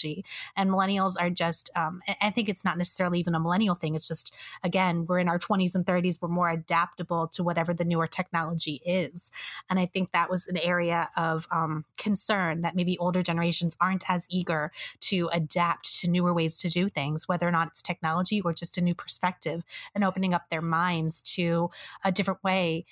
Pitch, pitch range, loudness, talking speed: 175 Hz, 165-185 Hz, -27 LUFS, 200 wpm